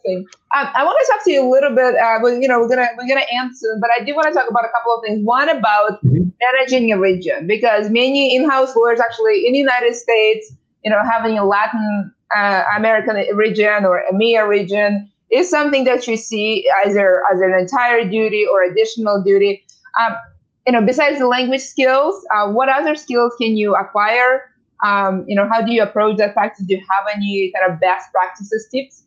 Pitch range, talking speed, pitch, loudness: 205-255 Hz, 205 wpm, 225 Hz, -15 LUFS